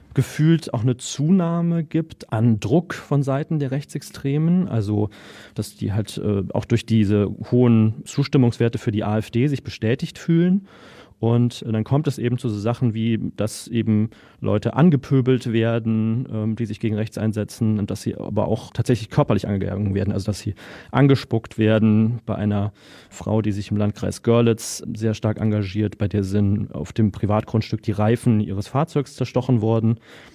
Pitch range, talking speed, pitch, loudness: 105-130 Hz, 165 wpm, 115 Hz, -21 LUFS